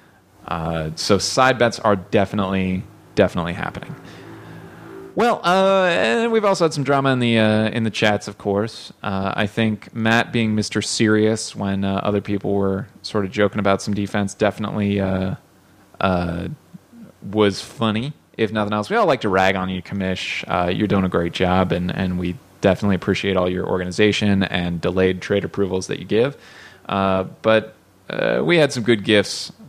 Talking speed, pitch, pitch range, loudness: 175 wpm, 100 Hz, 95-110 Hz, -20 LUFS